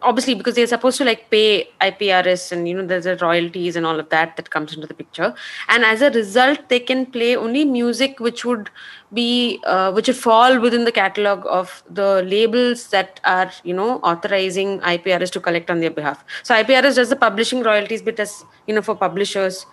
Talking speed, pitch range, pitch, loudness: 205 wpm, 185-240 Hz, 210 Hz, -17 LUFS